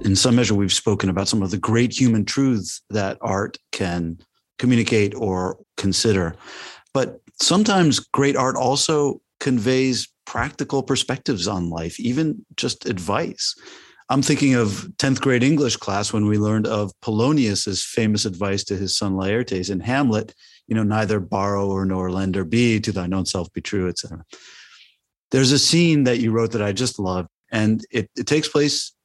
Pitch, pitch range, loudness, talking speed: 110 Hz, 100-130 Hz, -21 LUFS, 170 wpm